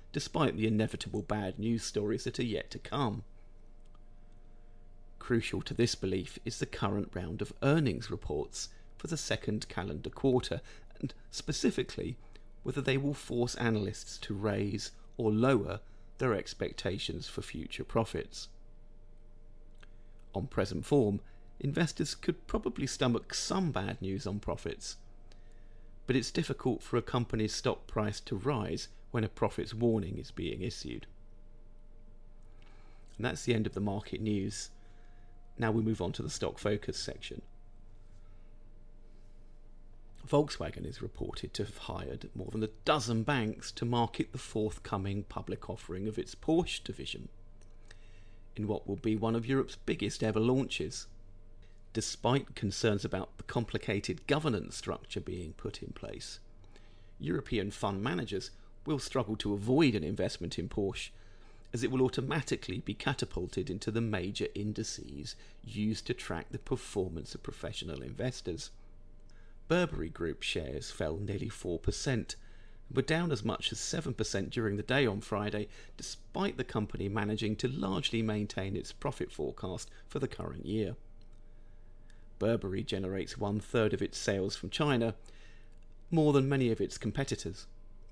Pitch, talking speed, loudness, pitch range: 110 Hz, 140 wpm, -35 LUFS, 100-115 Hz